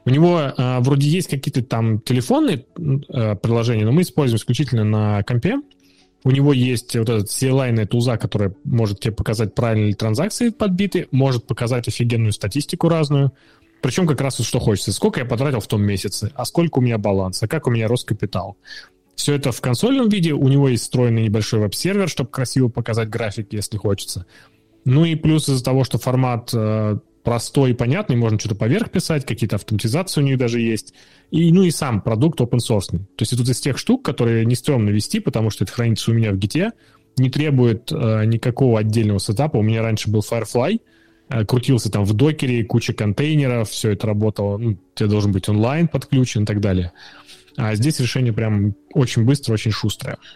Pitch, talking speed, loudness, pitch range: 120 Hz, 190 wpm, -19 LUFS, 110-140 Hz